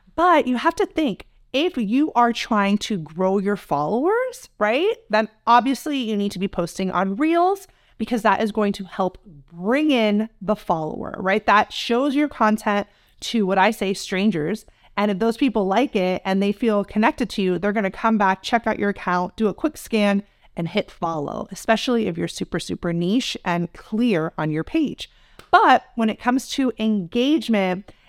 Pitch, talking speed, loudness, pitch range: 215 Hz, 185 wpm, -21 LUFS, 190-245 Hz